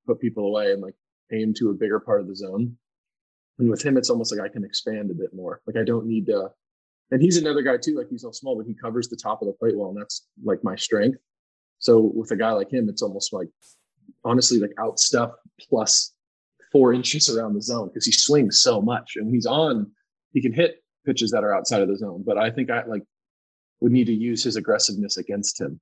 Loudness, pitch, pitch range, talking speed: -22 LUFS, 120 Hz, 110-160 Hz, 240 wpm